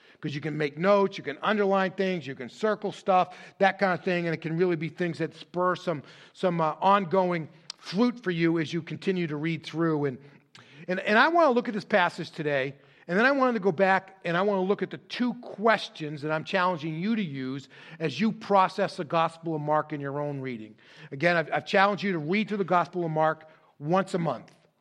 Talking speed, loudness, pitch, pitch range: 235 wpm, -27 LUFS, 175 Hz, 155-195 Hz